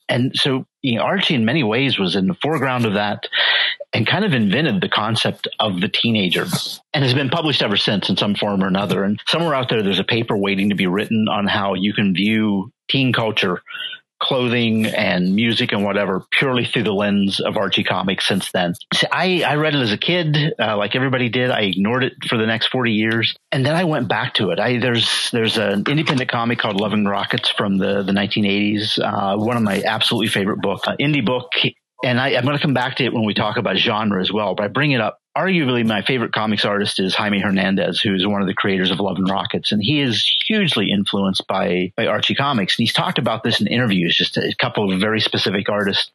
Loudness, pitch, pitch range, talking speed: -18 LUFS, 110 Hz, 100-125 Hz, 230 wpm